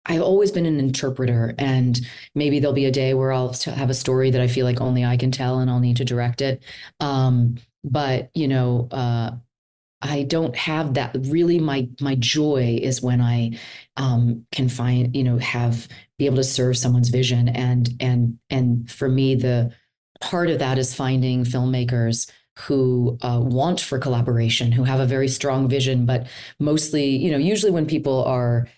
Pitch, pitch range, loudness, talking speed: 130 Hz, 120-135 Hz, -21 LUFS, 185 wpm